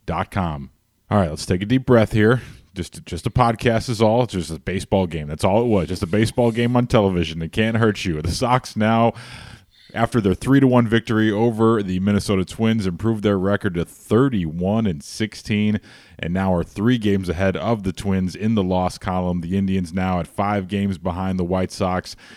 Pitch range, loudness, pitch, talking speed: 90-115 Hz, -20 LUFS, 100 Hz, 205 wpm